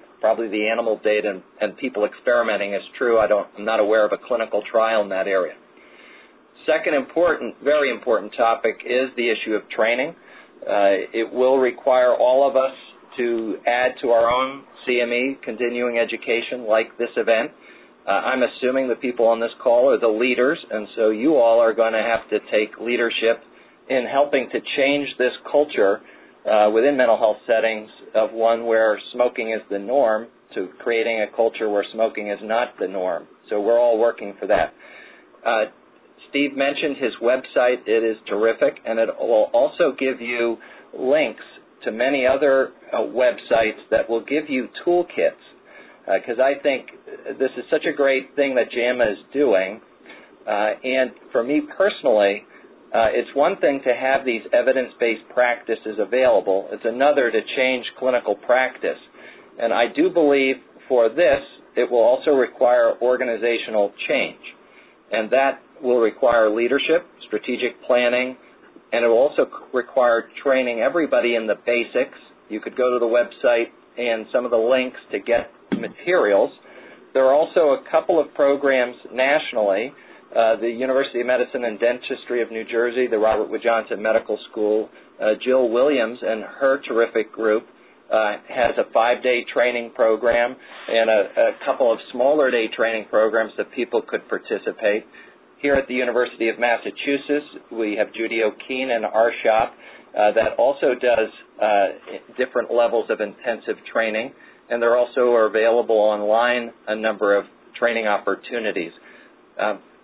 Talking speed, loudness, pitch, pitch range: 160 wpm, -20 LUFS, 120 Hz, 115-130 Hz